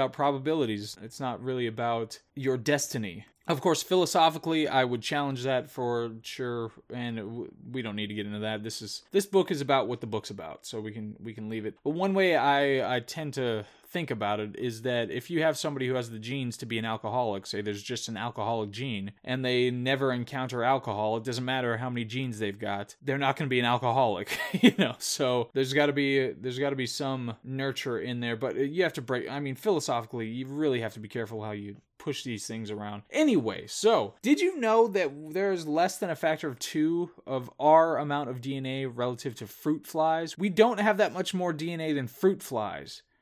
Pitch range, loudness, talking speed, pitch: 115-150 Hz, -29 LUFS, 220 wpm, 130 Hz